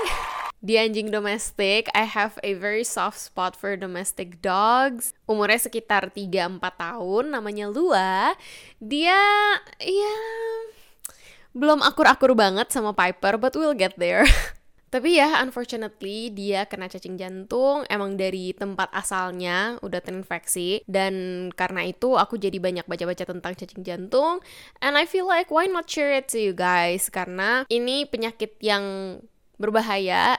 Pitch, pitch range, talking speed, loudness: 210 Hz, 190-255 Hz, 135 wpm, -23 LUFS